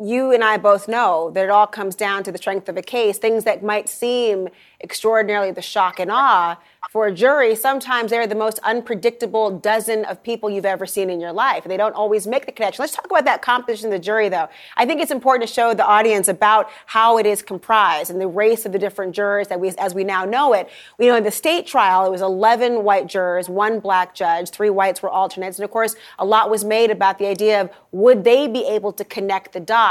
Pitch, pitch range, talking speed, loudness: 210 Hz, 195-225 Hz, 245 wpm, -18 LUFS